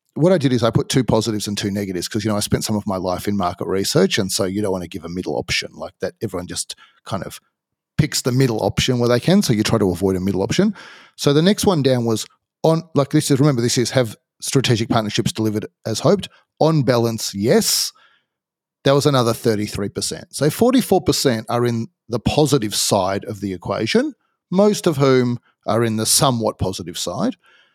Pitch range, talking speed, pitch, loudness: 105-145 Hz, 215 wpm, 120 Hz, -19 LUFS